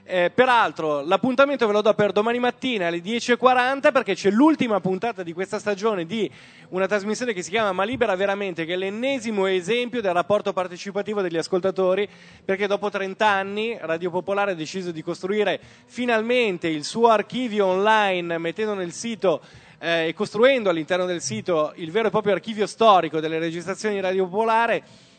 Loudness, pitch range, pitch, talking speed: -22 LUFS, 180-225 Hz, 200 Hz, 165 wpm